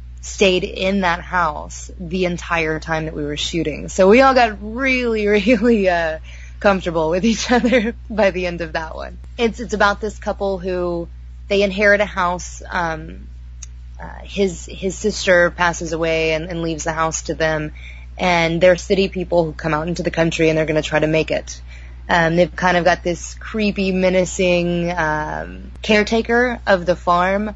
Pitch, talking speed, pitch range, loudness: 175 Hz, 180 wpm, 160-200 Hz, -18 LUFS